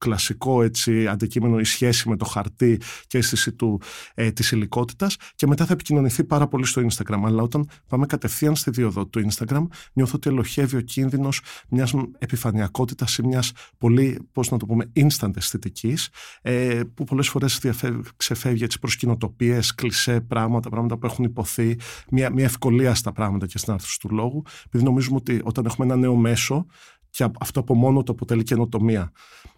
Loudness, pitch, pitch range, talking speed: -22 LUFS, 120 Hz, 115-130 Hz, 175 wpm